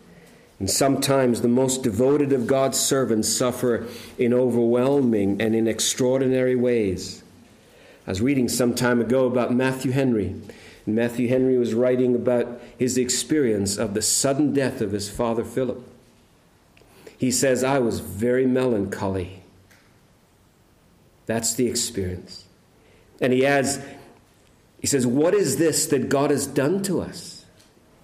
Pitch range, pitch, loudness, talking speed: 115-130 Hz, 125 Hz, -22 LUFS, 135 wpm